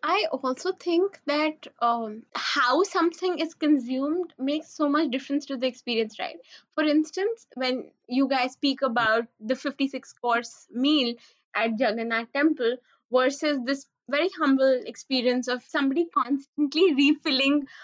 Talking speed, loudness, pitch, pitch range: 130 wpm, -26 LUFS, 275 Hz, 255-310 Hz